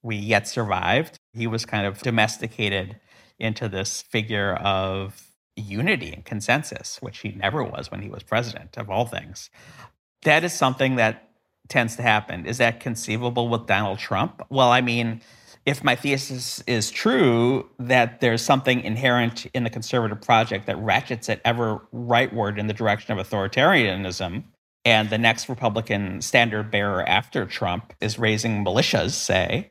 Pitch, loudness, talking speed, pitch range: 115 Hz, -22 LUFS, 155 wpm, 105-120 Hz